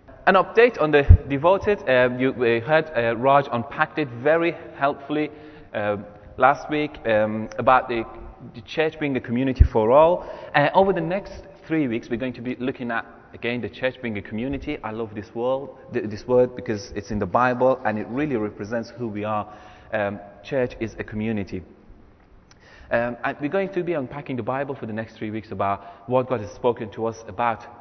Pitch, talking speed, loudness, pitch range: 125 Hz, 200 wpm, -23 LUFS, 110-145 Hz